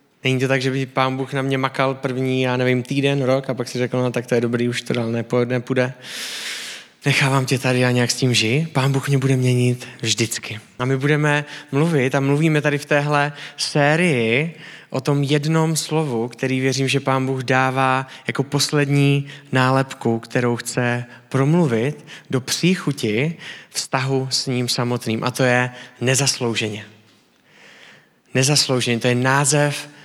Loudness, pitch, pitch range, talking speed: -20 LUFS, 130 Hz, 125-140 Hz, 165 wpm